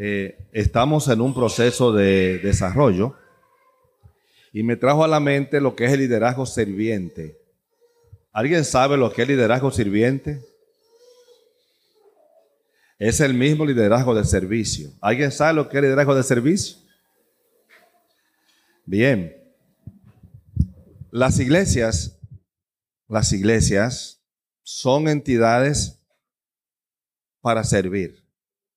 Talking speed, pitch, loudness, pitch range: 105 wpm, 130 Hz, -20 LUFS, 110-150 Hz